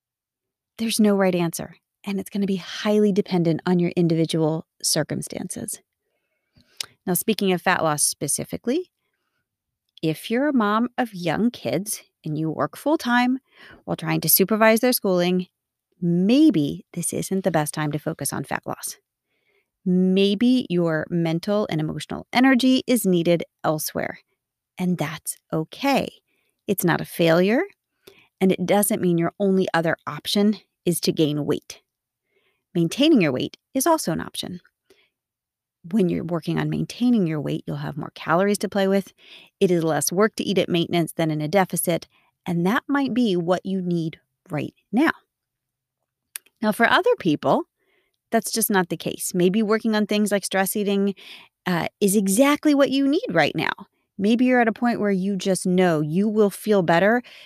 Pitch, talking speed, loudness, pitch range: 195 Hz, 165 wpm, -22 LUFS, 170-225 Hz